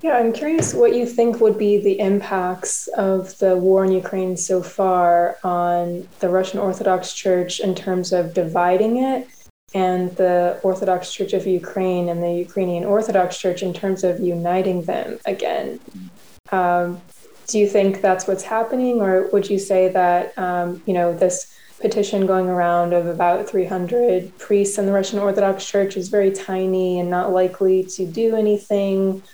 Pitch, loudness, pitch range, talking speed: 190 Hz, -19 LUFS, 180-200 Hz, 170 wpm